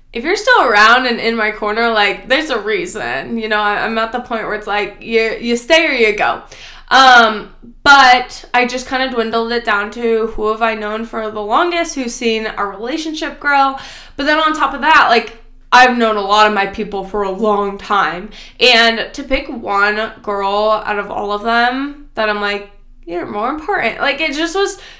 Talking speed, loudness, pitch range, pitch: 210 wpm, -14 LUFS, 210-270 Hz, 230 Hz